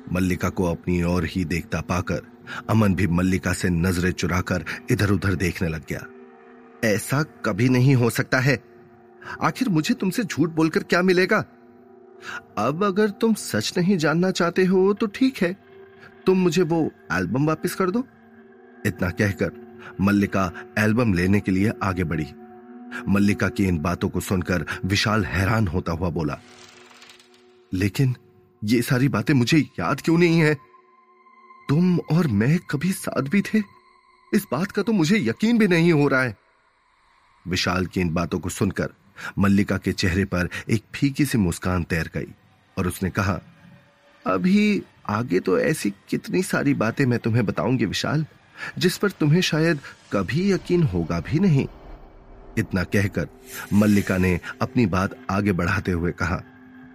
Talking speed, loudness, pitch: 150 wpm, -22 LUFS, 120 Hz